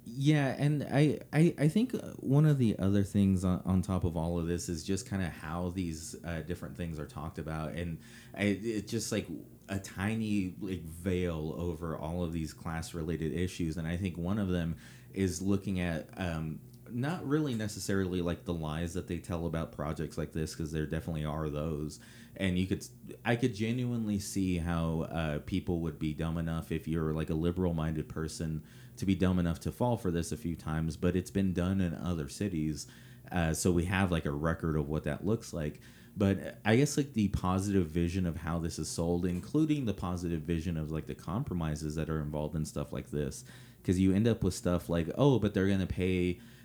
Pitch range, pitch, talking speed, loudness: 80-100 Hz, 90 Hz, 210 wpm, -33 LUFS